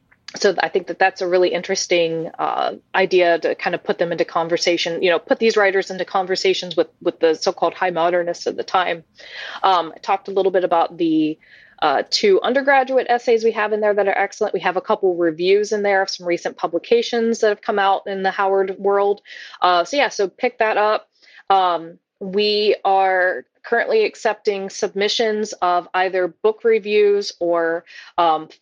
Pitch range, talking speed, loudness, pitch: 180-215 Hz, 190 wpm, -19 LUFS, 195 Hz